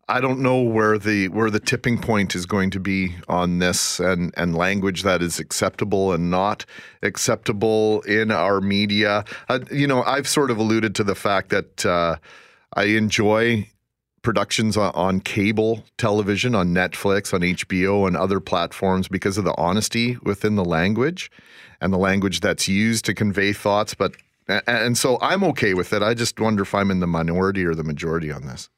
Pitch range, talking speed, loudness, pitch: 95-110 Hz, 185 wpm, -21 LUFS, 100 Hz